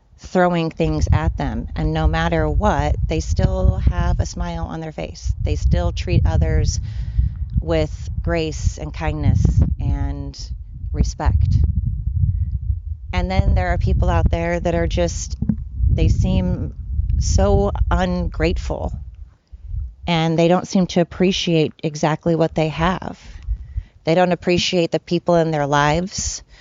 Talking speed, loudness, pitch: 130 wpm, -20 LUFS, 90 Hz